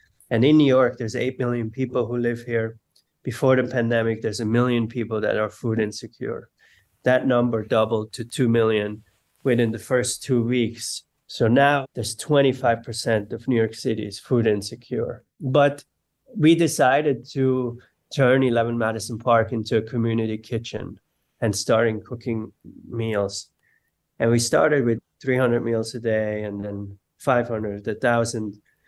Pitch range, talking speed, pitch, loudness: 110-125 Hz, 150 wpm, 115 Hz, -22 LUFS